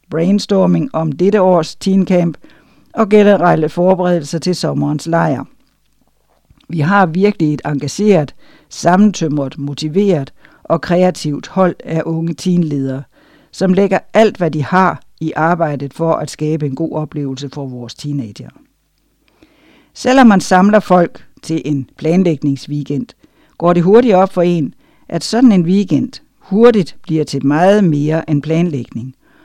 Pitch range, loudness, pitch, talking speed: 145-185 Hz, -14 LUFS, 165 Hz, 130 wpm